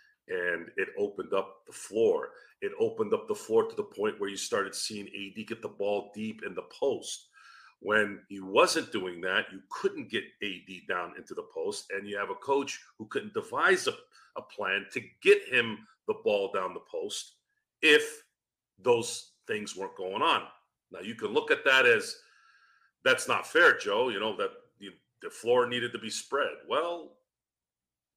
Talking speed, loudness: 185 wpm, -30 LUFS